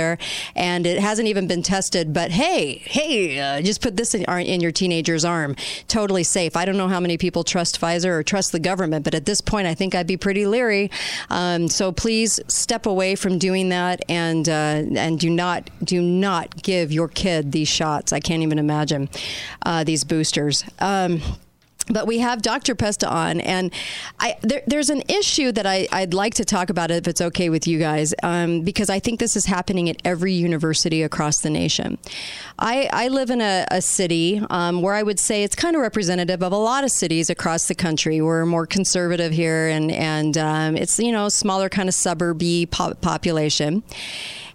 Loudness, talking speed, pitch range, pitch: -20 LUFS, 200 wpm, 165-200 Hz, 180 Hz